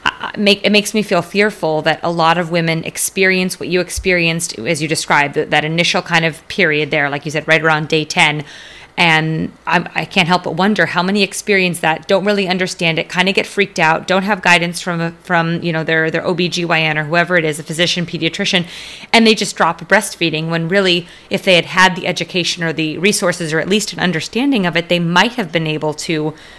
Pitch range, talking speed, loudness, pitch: 160-190 Hz, 220 wpm, -14 LUFS, 175 Hz